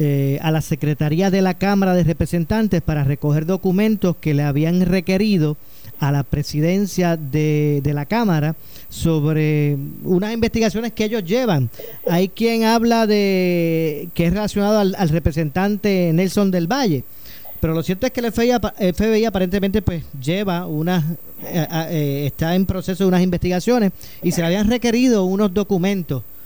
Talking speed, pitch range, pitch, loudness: 160 wpm, 155-205 Hz, 180 Hz, -19 LUFS